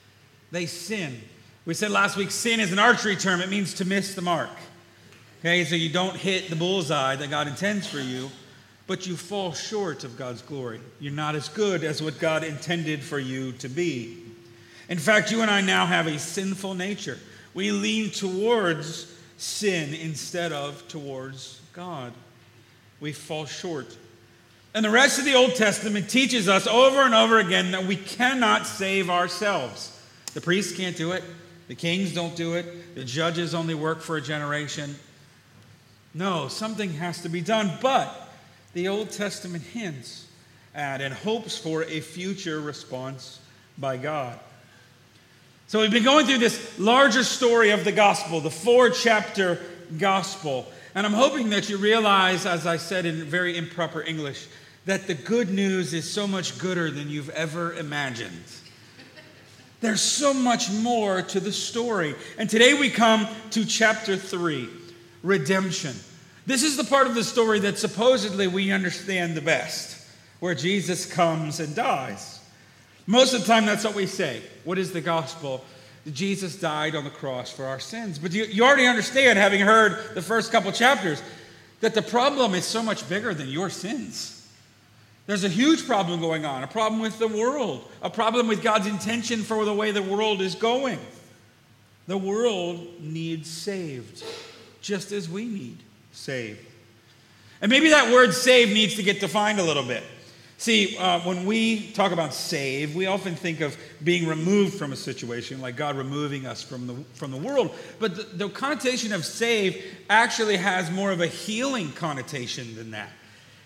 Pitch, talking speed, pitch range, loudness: 175 Hz, 170 wpm, 145-210 Hz, -24 LUFS